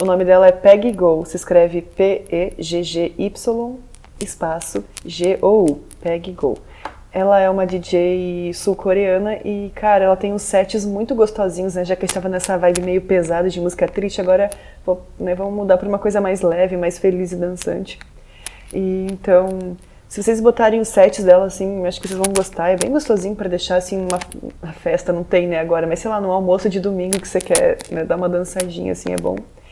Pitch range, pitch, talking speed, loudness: 180-200 Hz, 185 Hz, 195 wpm, -17 LUFS